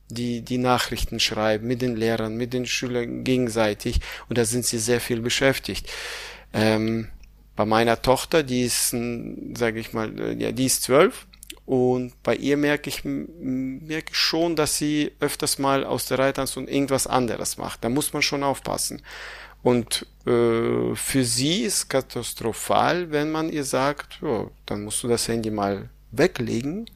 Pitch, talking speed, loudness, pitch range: 125 Hz, 160 wpm, -24 LUFS, 115-140 Hz